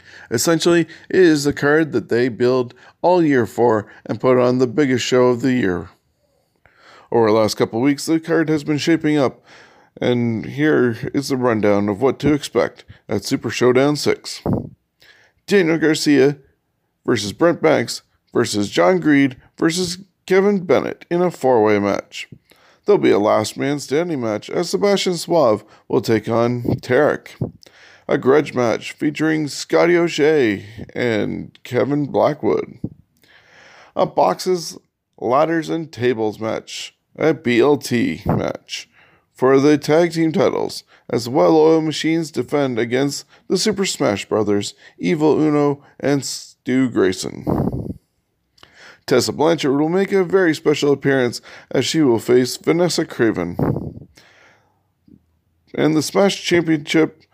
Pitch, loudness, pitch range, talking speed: 140 Hz, -18 LUFS, 120-160 Hz, 135 wpm